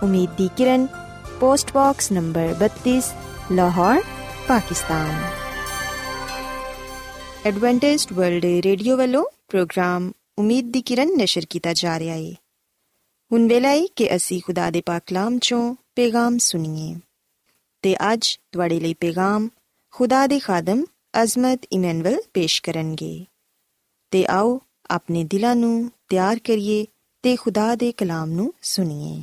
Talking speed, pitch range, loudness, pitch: 95 wpm, 170-245 Hz, -21 LUFS, 195 Hz